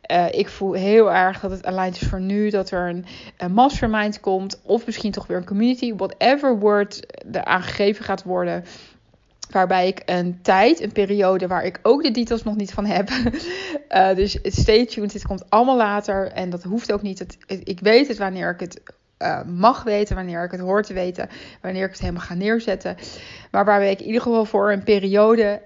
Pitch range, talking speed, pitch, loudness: 185-225 Hz, 205 wpm, 205 Hz, -20 LUFS